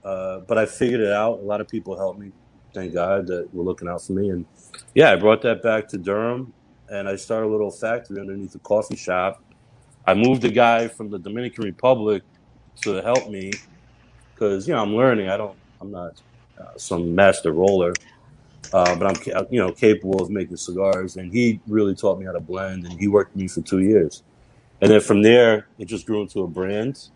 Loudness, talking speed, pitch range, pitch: -21 LUFS, 215 wpm, 95-115 Hz, 105 Hz